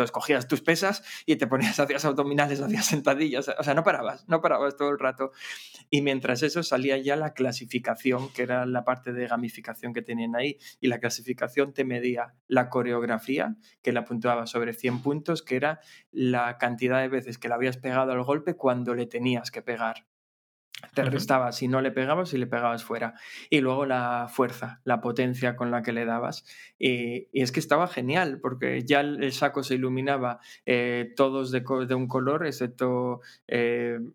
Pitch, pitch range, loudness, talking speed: 130 Hz, 120-140 Hz, -27 LUFS, 190 wpm